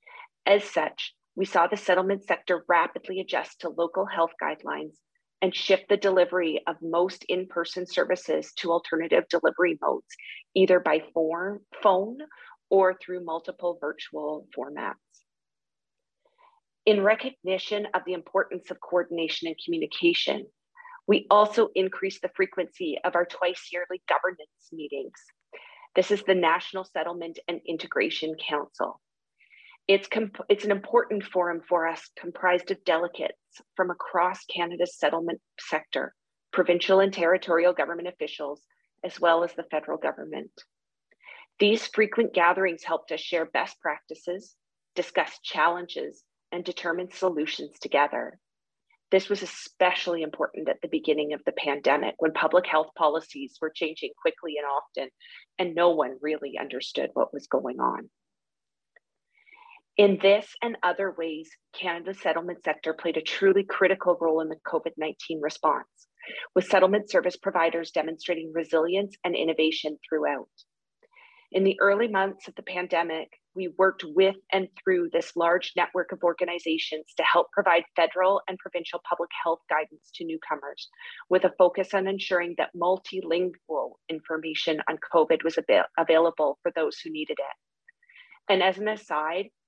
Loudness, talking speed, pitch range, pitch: -26 LUFS, 140 wpm, 165-200 Hz, 180 Hz